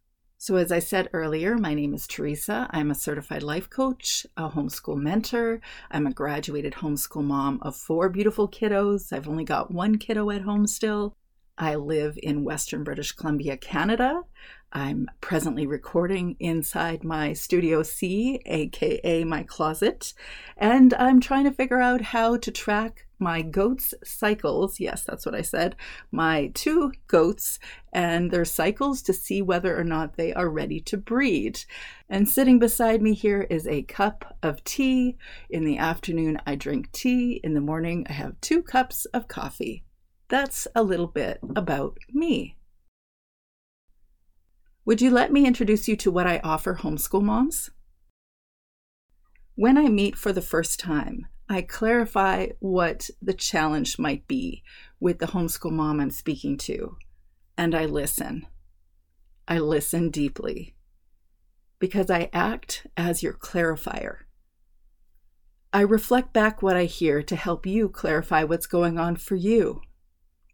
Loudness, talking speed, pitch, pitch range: -25 LUFS, 150 wpm, 175 Hz, 150-220 Hz